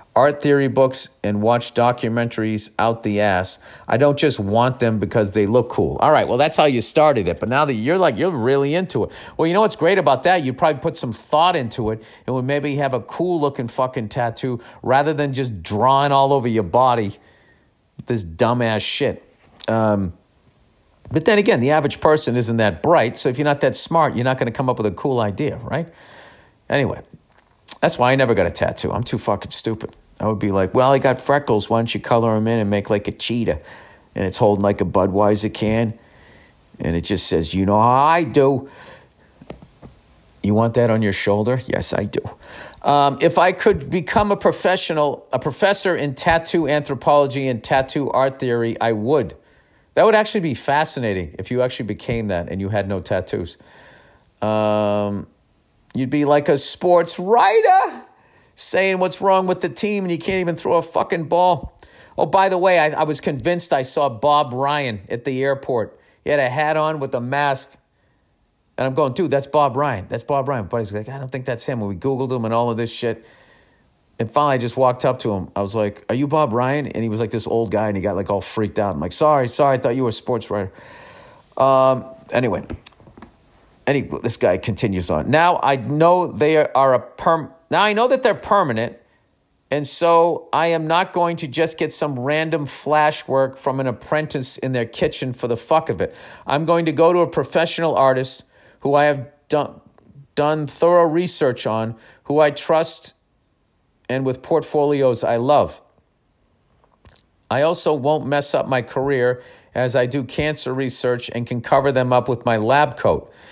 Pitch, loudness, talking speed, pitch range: 130 Hz, -19 LUFS, 205 wpm, 115-150 Hz